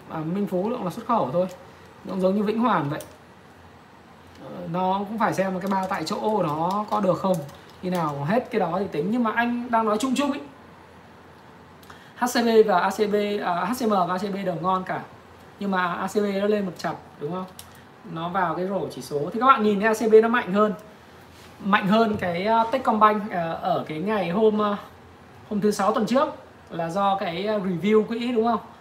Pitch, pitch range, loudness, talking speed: 205 Hz, 180-220 Hz, -24 LUFS, 210 wpm